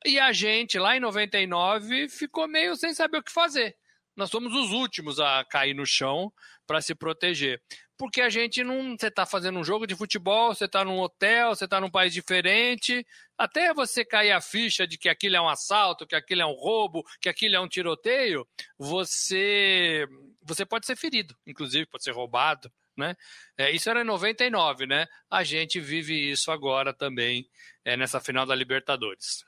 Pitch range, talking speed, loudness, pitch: 160-235 Hz, 185 wpm, -25 LUFS, 190 Hz